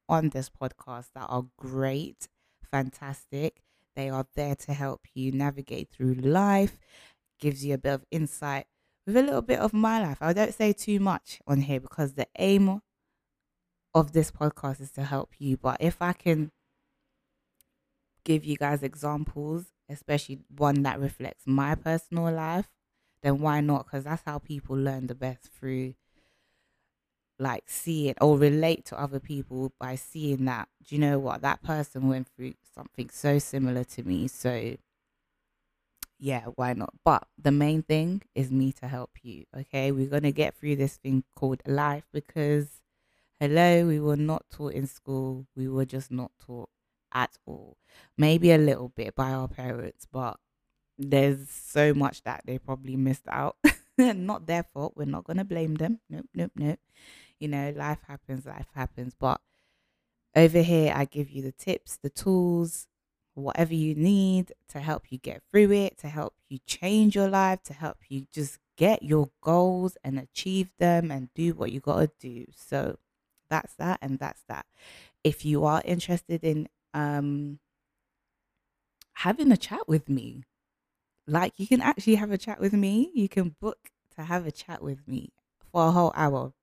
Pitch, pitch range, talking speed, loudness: 145 Hz, 135-165 Hz, 170 wpm, -28 LUFS